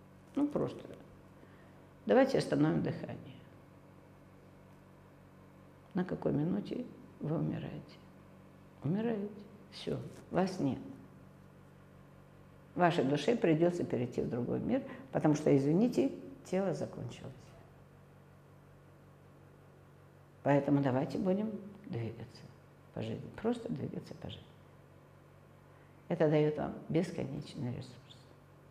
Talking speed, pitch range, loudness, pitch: 80 wpm, 135-195 Hz, -34 LUFS, 150 Hz